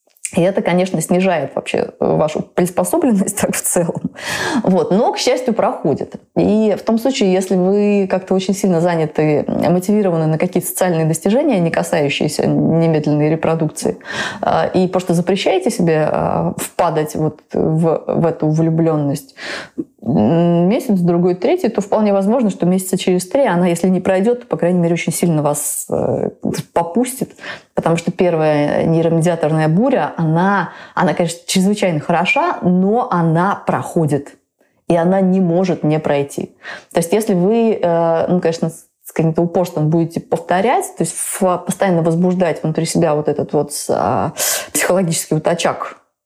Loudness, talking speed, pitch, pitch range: -16 LUFS, 140 wpm, 175 Hz, 165-195 Hz